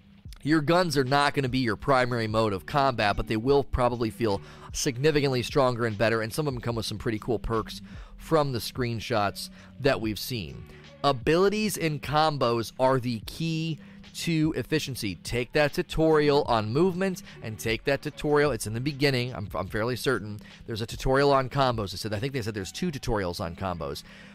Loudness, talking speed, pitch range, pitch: -27 LUFS, 190 wpm, 110-145 Hz, 125 Hz